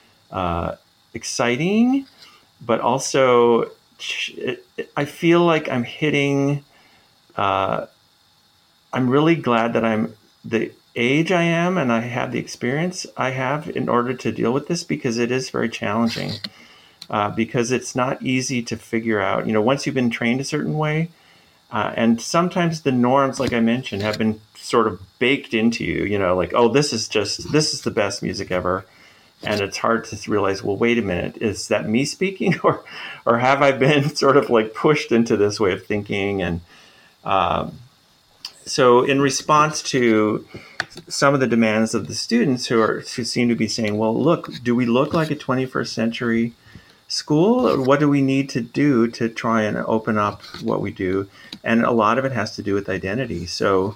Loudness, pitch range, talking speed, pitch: -20 LUFS, 110-140 Hz, 185 wpm, 120 Hz